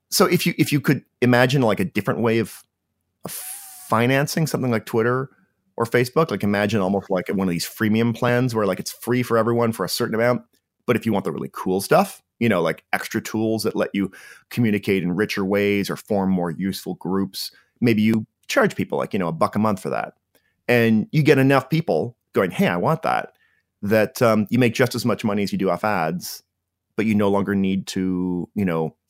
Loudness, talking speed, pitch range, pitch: -21 LUFS, 220 wpm, 95-120 Hz, 110 Hz